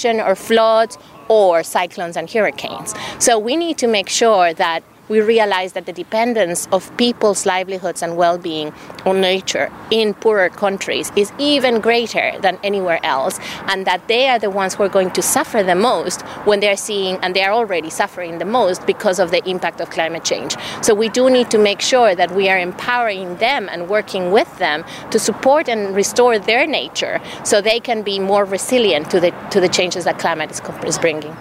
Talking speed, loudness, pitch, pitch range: 195 wpm, -16 LUFS, 200 Hz, 180-225 Hz